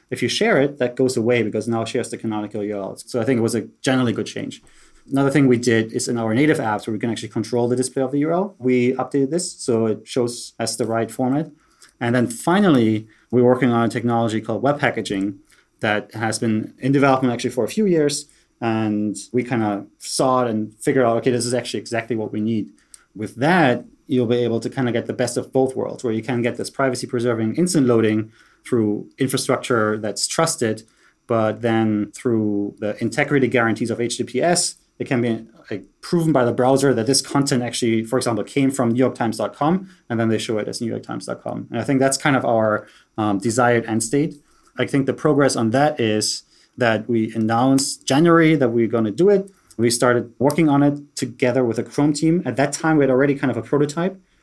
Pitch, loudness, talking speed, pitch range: 120 Hz, -20 LUFS, 220 wpm, 115-135 Hz